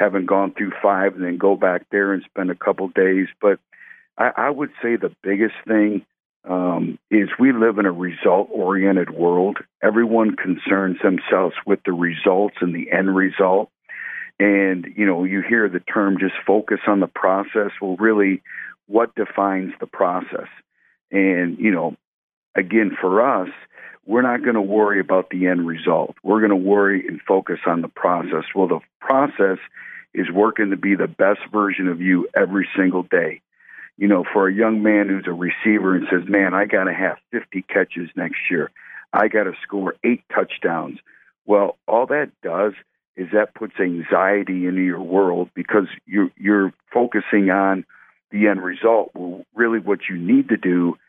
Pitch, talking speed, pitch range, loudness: 95 Hz, 175 wpm, 90-105 Hz, -19 LUFS